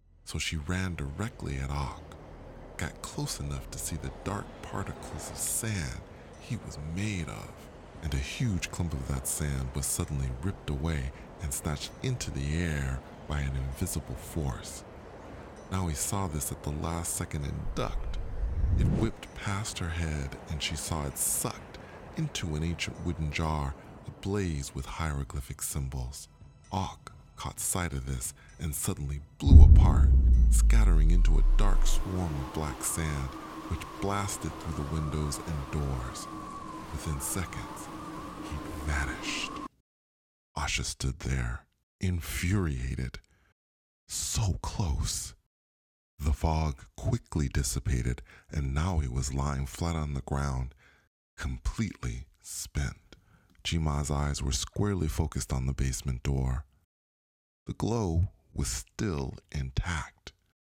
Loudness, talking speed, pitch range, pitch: -31 LUFS, 130 wpm, 70-85 Hz, 75 Hz